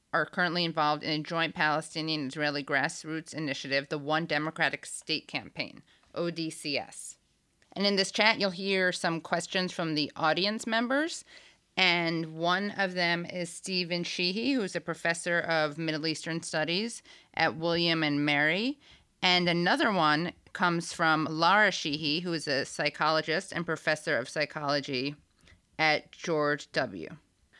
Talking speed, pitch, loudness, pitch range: 140 wpm, 165 Hz, -29 LUFS, 155-180 Hz